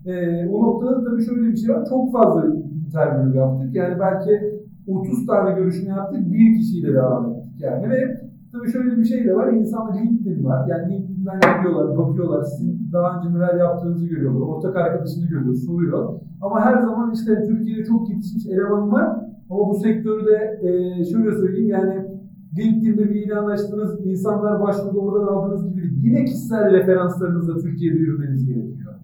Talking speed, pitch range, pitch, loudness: 165 wpm, 170-215 Hz, 195 Hz, -20 LUFS